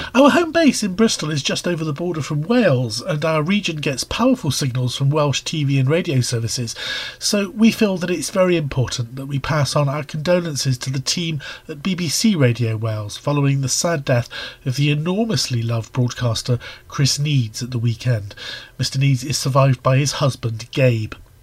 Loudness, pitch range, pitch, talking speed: -19 LUFS, 125-170 Hz, 140 Hz, 185 wpm